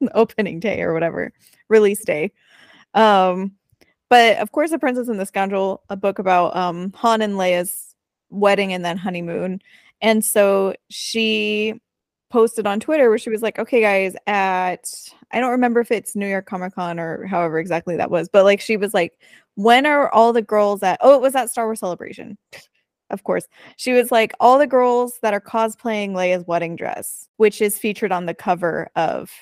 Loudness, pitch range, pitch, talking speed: -18 LUFS, 185-230 Hz, 210 Hz, 185 wpm